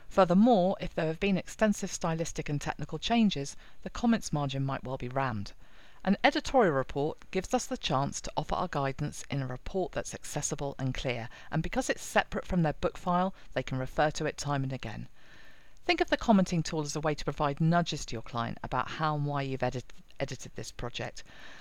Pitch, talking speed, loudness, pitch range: 155 Hz, 205 wpm, -31 LUFS, 135-185 Hz